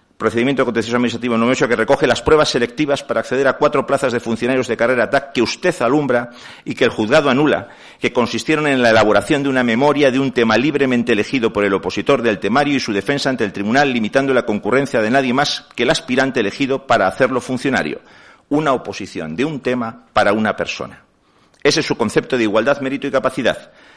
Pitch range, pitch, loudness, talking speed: 115-140 Hz, 130 Hz, -16 LUFS, 205 wpm